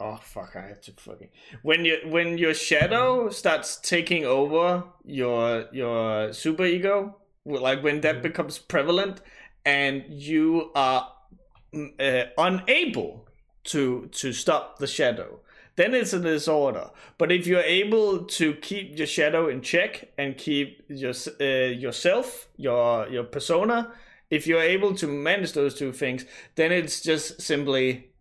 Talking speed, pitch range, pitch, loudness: 145 wpm, 135-180 Hz, 155 Hz, -24 LUFS